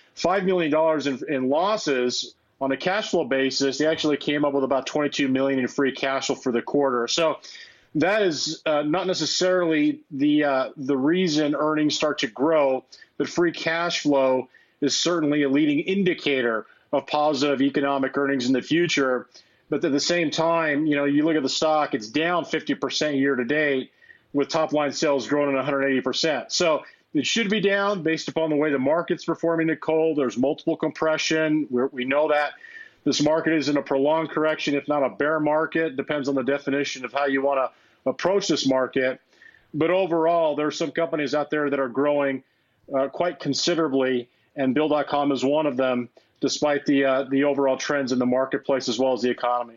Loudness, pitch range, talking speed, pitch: -23 LUFS, 135-160 Hz, 200 wpm, 145 Hz